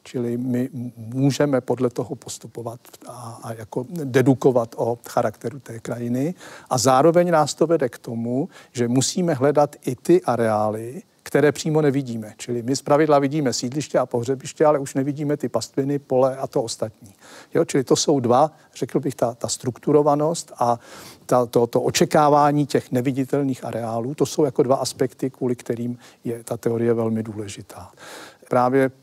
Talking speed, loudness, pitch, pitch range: 160 wpm, -21 LUFS, 130 Hz, 120-145 Hz